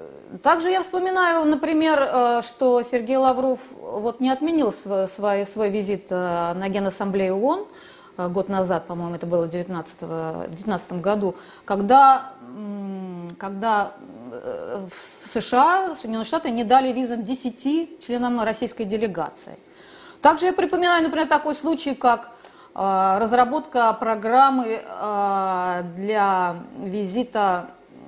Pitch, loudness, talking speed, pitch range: 235 Hz, -21 LUFS, 105 wpm, 195-280 Hz